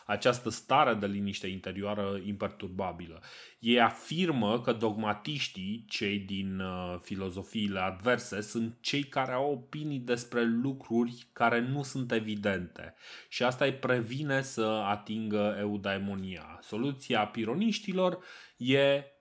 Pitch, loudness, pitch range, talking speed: 115 Hz, -32 LUFS, 100-135 Hz, 110 wpm